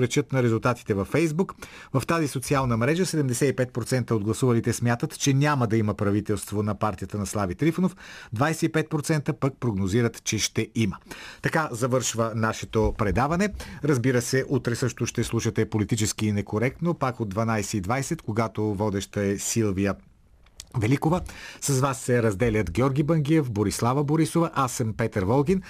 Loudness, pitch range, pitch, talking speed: -25 LUFS, 110-145 Hz, 120 Hz, 140 wpm